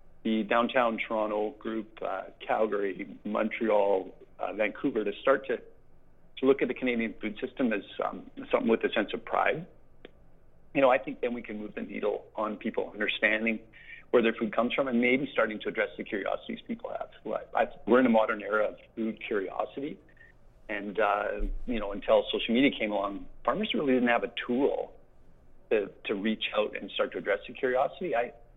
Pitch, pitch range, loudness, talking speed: 115 Hz, 110-135 Hz, -30 LUFS, 190 wpm